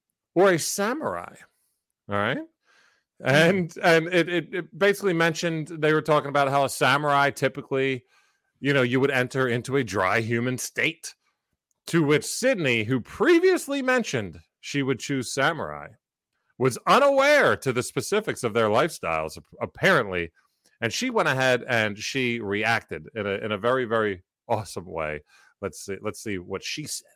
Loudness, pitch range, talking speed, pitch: -24 LUFS, 115-170 Hz, 155 wpm, 135 Hz